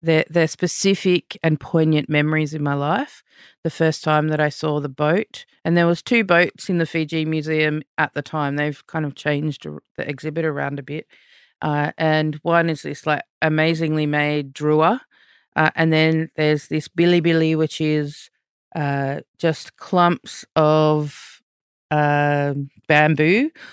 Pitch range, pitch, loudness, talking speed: 150-165 Hz, 155 Hz, -20 LUFS, 155 wpm